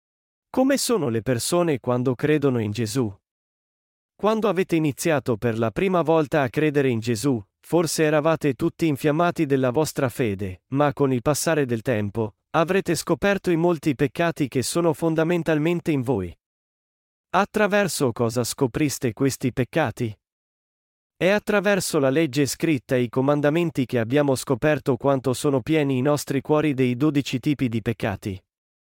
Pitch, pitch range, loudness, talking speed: 145 Hz, 125-165 Hz, -23 LUFS, 145 wpm